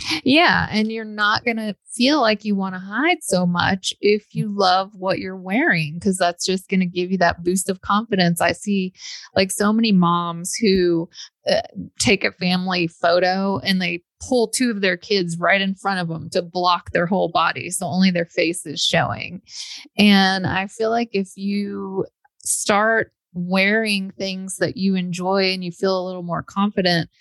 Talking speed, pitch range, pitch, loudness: 185 wpm, 180-210 Hz, 190 Hz, -20 LUFS